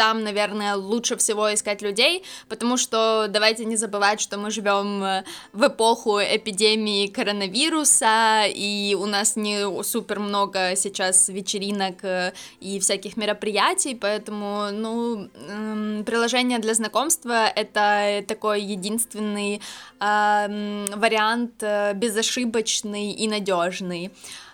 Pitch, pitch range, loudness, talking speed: 210 Hz, 205-225 Hz, -22 LUFS, 100 wpm